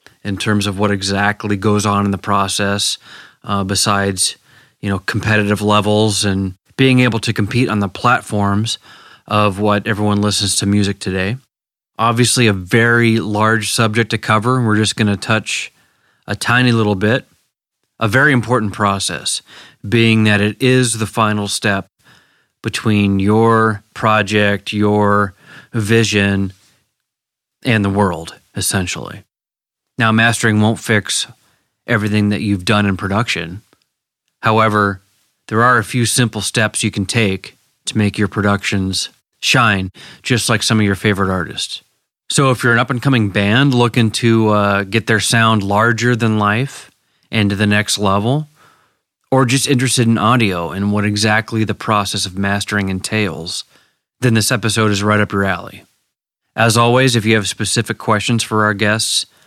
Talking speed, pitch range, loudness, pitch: 155 wpm, 100-115 Hz, -15 LUFS, 105 Hz